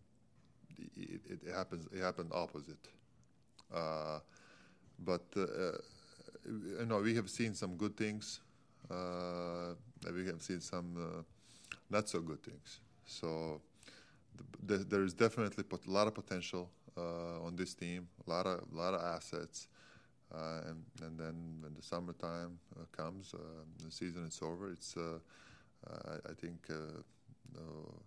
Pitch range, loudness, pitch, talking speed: 80-95 Hz, -43 LUFS, 85 Hz, 150 wpm